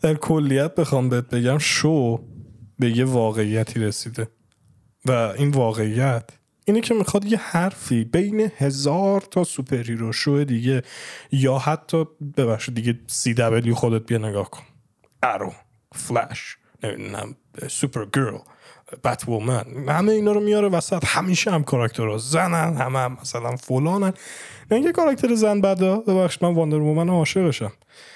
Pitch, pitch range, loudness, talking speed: 135 Hz, 115-170 Hz, -22 LUFS, 140 wpm